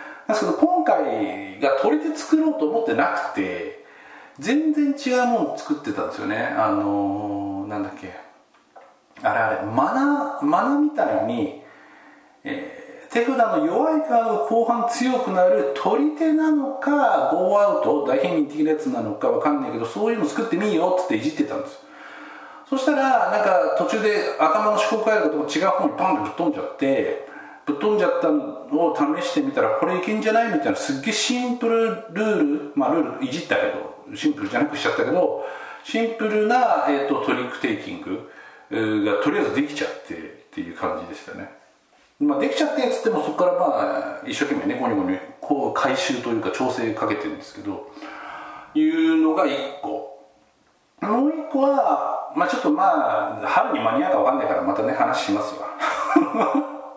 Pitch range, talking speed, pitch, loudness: 220-305 Hz, 370 characters per minute, 270 Hz, -22 LUFS